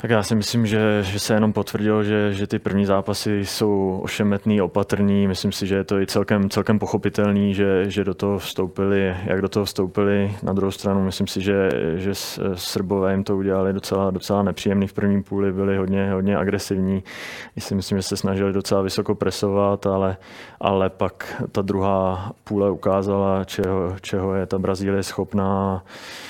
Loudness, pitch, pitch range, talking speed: -22 LUFS, 100 Hz, 95-100 Hz, 180 wpm